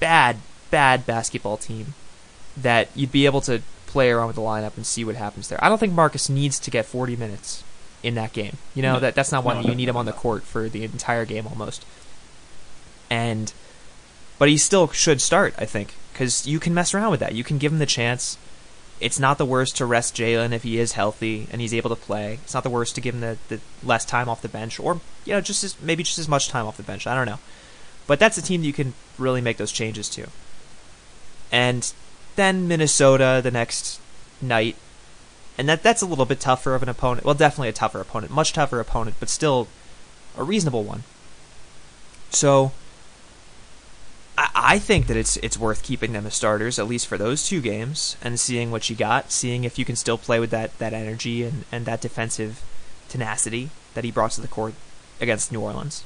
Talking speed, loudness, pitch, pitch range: 215 wpm, -22 LUFS, 120 Hz, 110-140 Hz